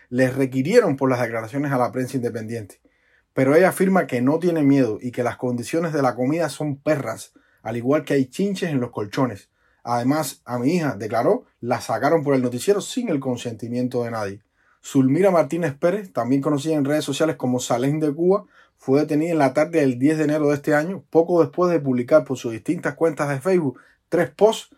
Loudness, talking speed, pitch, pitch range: -21 LUFS, 205 wpm, 140 Hz, 125-160 Hz